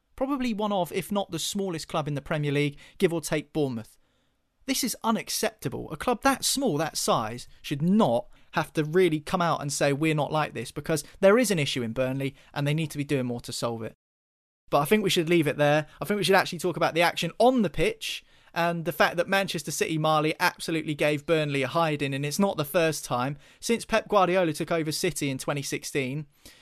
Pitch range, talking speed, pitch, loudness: 145-190 Hz, 230 wpm, 160 Hz, -26 LUFS